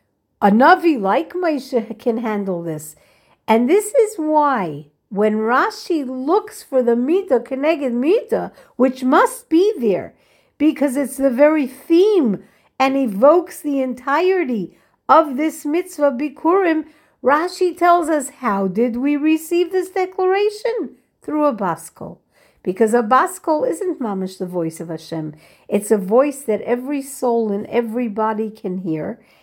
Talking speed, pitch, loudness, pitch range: 135 wpm, 275 Hz, -18 LUFS, 220-330 Hz